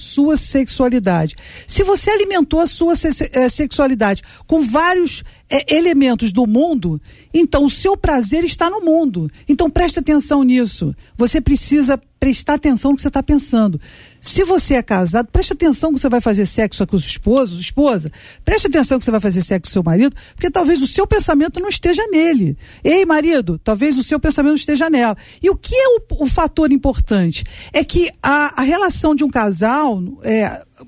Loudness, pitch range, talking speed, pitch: -15 LUFS, 235-325 Hz, 180 wpm, 285 Hz